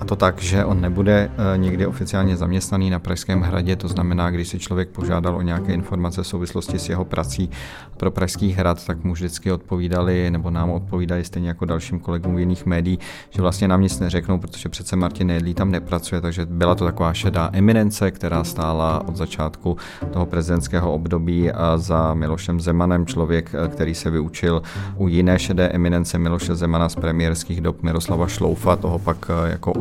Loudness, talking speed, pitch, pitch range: -21 LUFS, 175 wpm, 90 Hz, 85-95 Hz